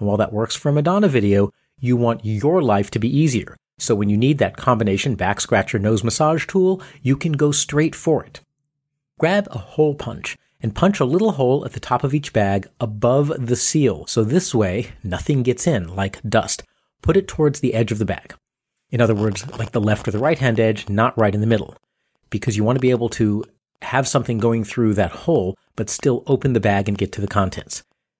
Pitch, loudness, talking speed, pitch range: 120 Hz, -19 LUFS, 220 wpm, 105-145 Hz